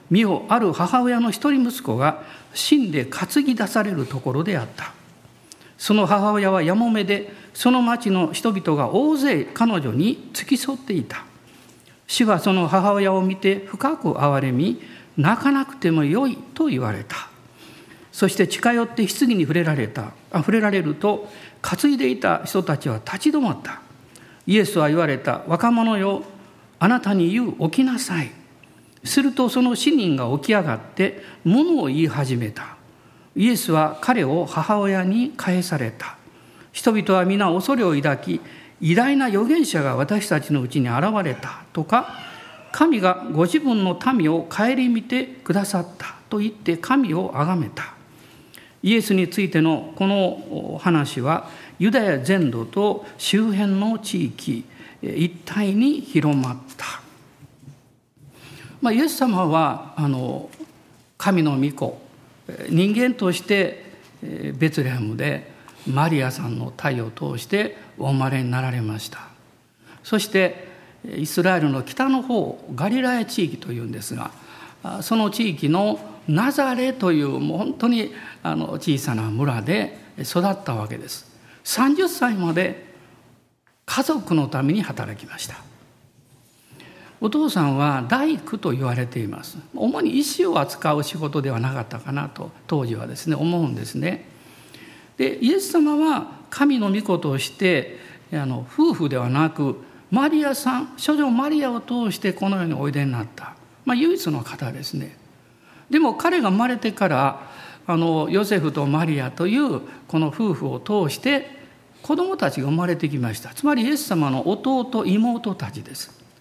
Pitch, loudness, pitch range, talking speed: 185 Hz, -21 LUFS, 145-235 Hz, 270 characters per minute